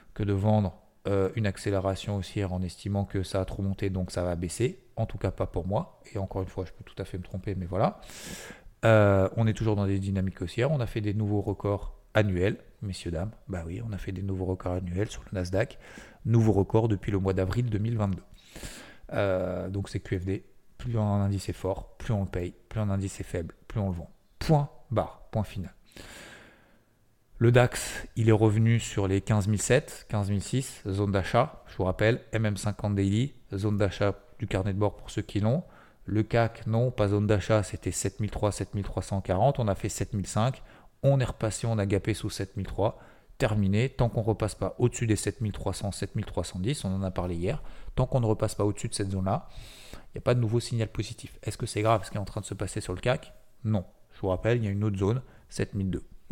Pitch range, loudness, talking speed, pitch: 95-110 Hz, -29 LUFS, 220 wpm, 105 Hz